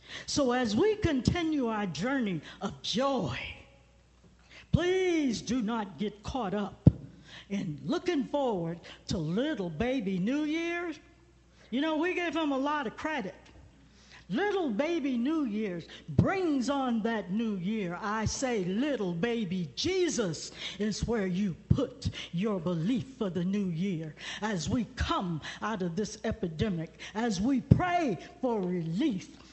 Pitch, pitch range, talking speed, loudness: 225 Hz, 190-280 Hz, 135 wpm, -31 LUFS